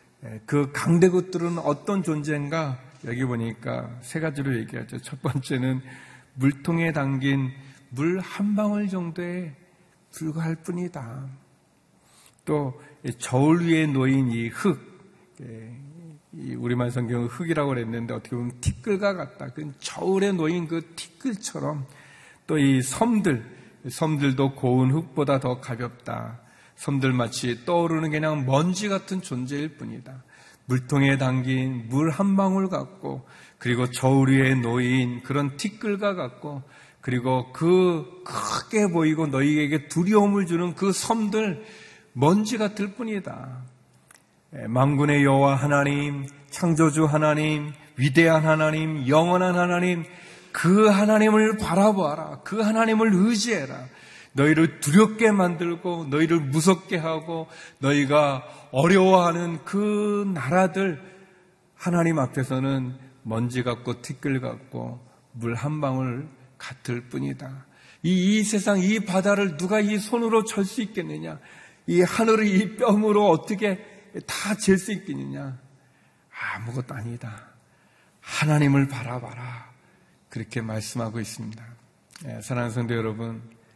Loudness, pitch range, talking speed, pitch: -24 LUFS, 130-185 Hz, 255 characters per minute, 150 Hz